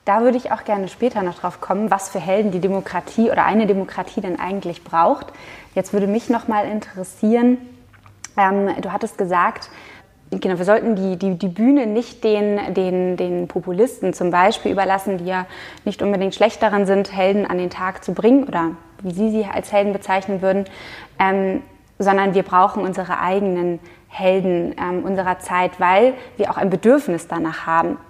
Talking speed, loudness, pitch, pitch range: 175 wpm, -19 LUFS, 195 Hz, 180-210 Hz